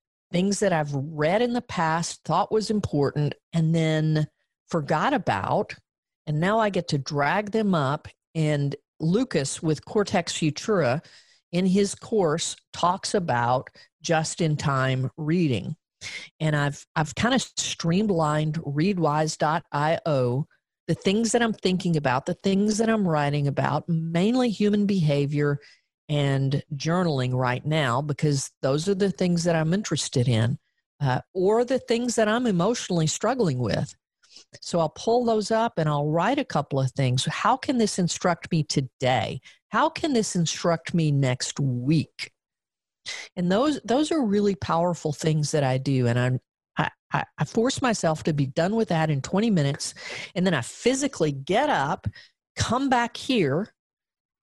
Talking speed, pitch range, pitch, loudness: 150 wpm, 145-200 Hz, 160 Hz, -25 LUFS